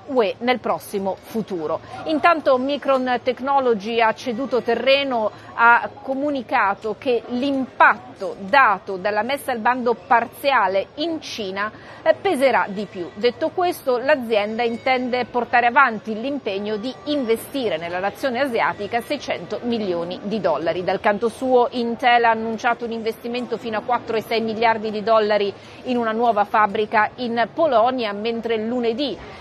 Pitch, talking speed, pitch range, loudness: 235 Hz, 125 wpm, 215-260 Hz, -20 LUFS